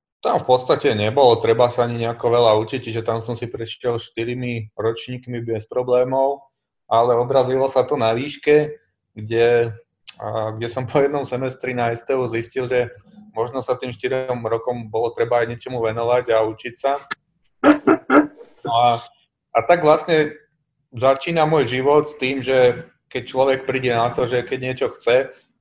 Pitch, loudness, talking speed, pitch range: 125 Hz, -20 LUFS, 160 wpm, 115-140 Hz